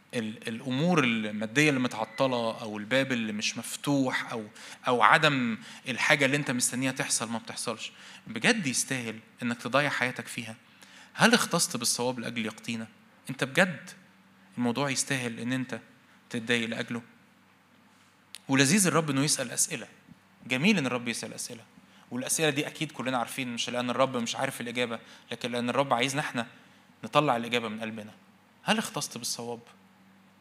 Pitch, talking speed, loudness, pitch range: 120 Hz, 140 wpm, -28 LUFS, 115-135 Hz